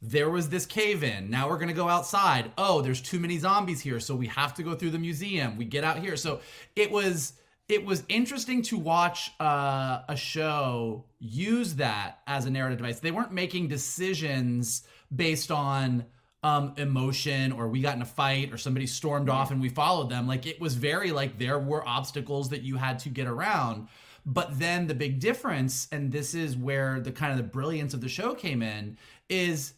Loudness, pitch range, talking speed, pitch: -29 LUFS, 130-170 Hz, 205 wpm, 145 Hz